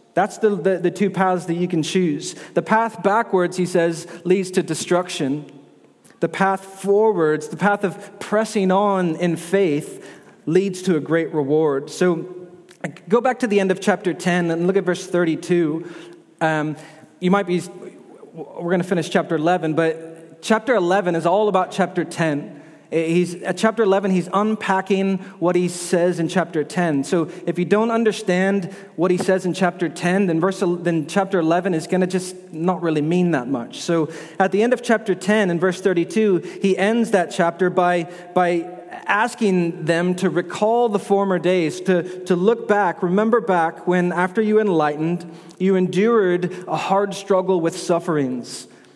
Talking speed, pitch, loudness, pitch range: 175 wpm, 180 Hz, -20 LUFS, 170-195 Hz